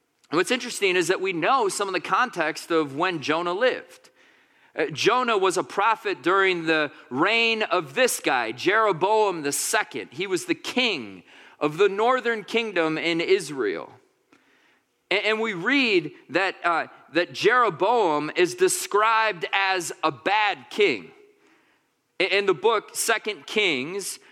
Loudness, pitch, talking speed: -23 LUFS, 225 Hz, 135 wpm